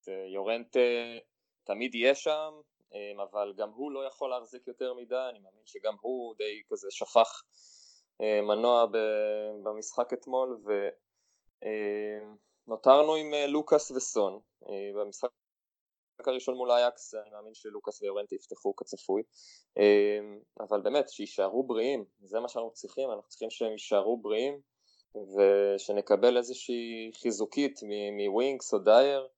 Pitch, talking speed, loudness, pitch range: 120 Hz, 115 wpm, -30 LUFS, 105-145 Hz